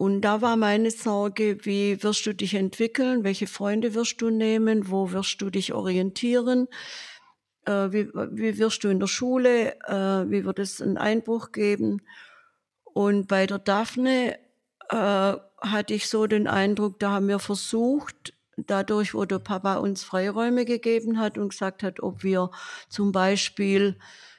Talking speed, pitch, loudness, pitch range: 155 wpm, 205 Hz, -25 LUFS, 195-230 Hz